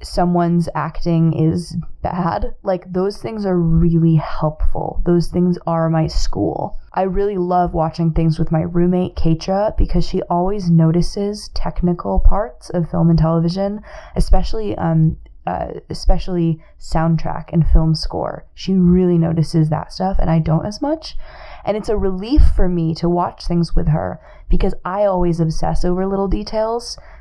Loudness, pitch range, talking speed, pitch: -18 LUFS, 165-190 Hz, 155 wpm, 175 Hz